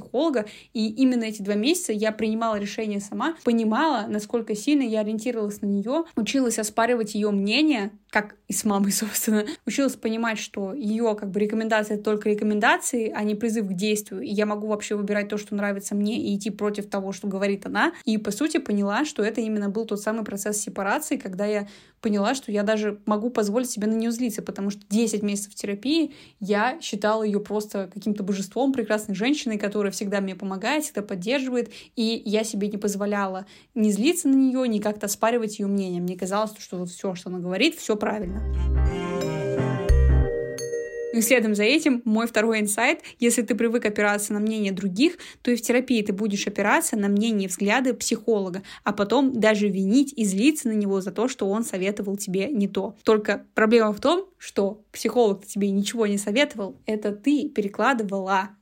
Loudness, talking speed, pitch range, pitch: -24 LUFS, 180 wpm, 205-235 Hz, 215 Hz